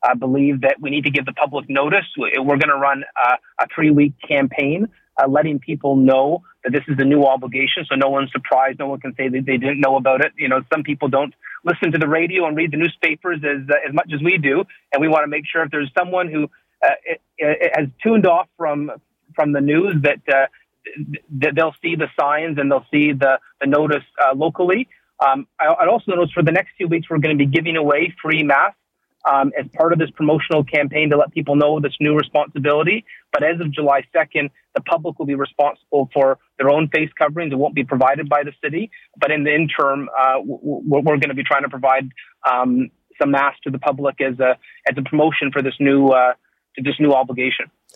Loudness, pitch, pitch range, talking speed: -18 LUFS, 145 Hz, 140-160 Hz, 230 wpm